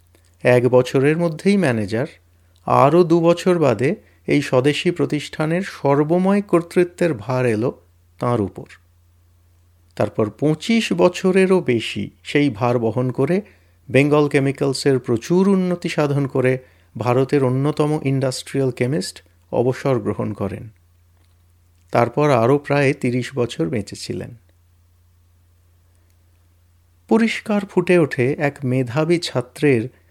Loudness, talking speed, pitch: -19 LUFS, 100 wpm, 125 Hz